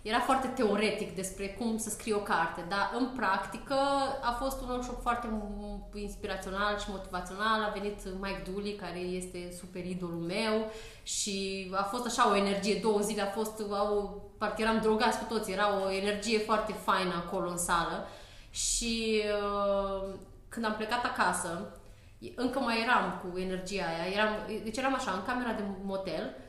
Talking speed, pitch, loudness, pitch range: 160 wpm, 205 Hz, -32 LUFS, 190-220 Hz